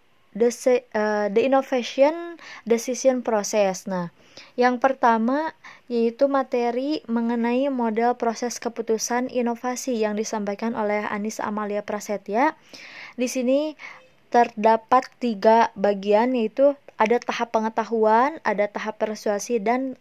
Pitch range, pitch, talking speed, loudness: 220-255 Hz, 235 Hz, 105 wpm, -23 LUFS